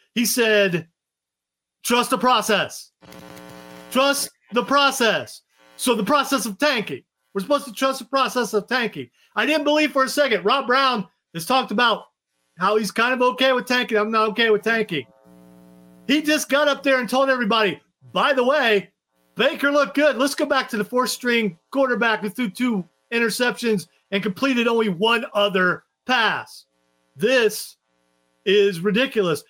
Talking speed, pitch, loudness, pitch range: 160 wpm, 230 Hz, -20 LUFS, 185-265 Hz